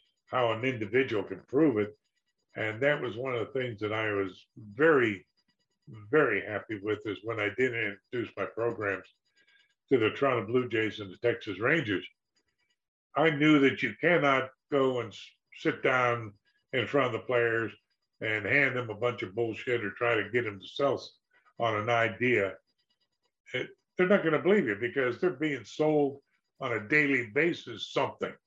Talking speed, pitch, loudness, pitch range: 175 wpm, 120 Hz, -29 LUFS, 110-140 Hz